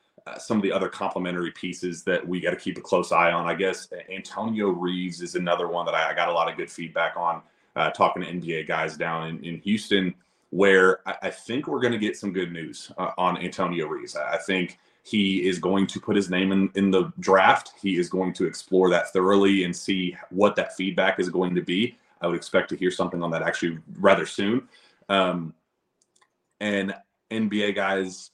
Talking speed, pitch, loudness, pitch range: 215 wpm, 90 Hz, -25 LUFS, 85-95 Hz